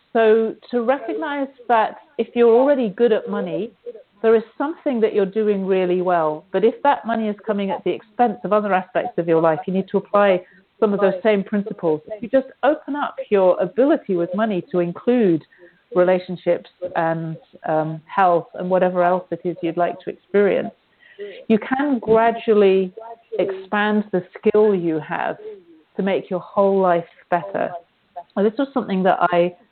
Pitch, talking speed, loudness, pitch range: 205 Hz, 175 wpm, -20 LUFS, 180-230 Hz